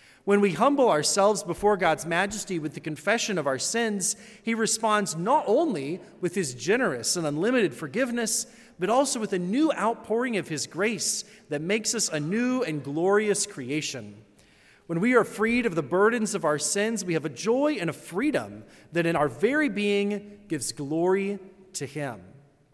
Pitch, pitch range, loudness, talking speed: 195 Hz, 155-220 Hz, -26 LUFS, 175 wpm